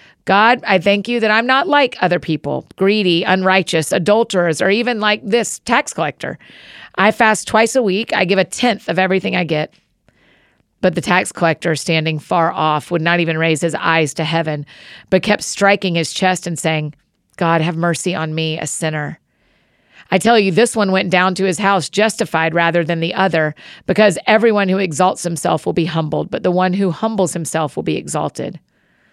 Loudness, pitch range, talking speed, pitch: -16 LUFS, 165-200 Hz, 190 wpm, 185 Hz